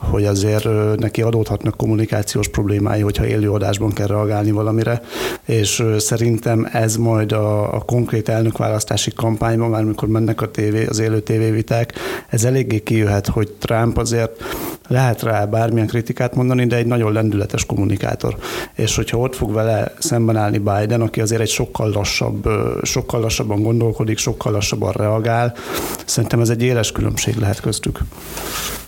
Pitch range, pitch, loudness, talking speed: 105-115 Hz, 110 Hz, -18 LUFS, 150 wpm